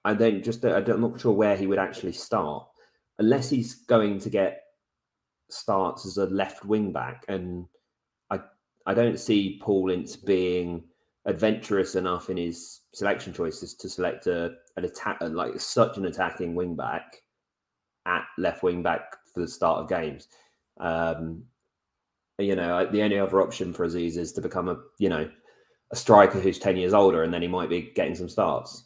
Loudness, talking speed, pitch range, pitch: -26 LUFS, 180 wpm, 85-105 Hz, 95 Hz